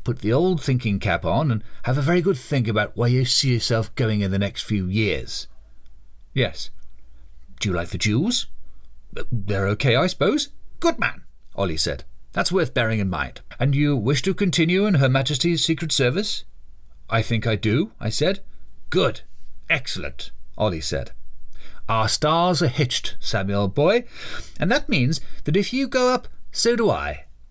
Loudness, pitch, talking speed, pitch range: -22 LUFS, 120 Hz, 170 wpm, 100-160 Hz